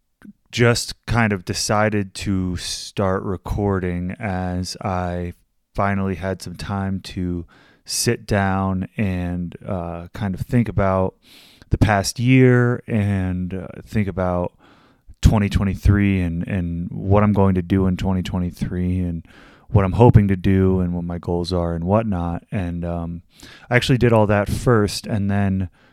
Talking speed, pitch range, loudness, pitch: 145 wpm, 90-105 Hz, -20 LUFS, 95 Hz